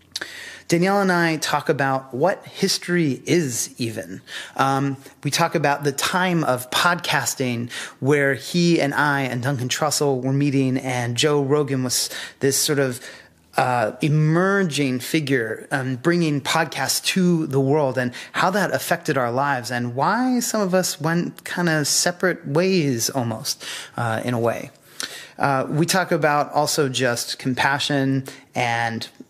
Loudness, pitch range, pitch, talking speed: -21 LUFS, 130-165 Hz, 140 Hz, 145 wpm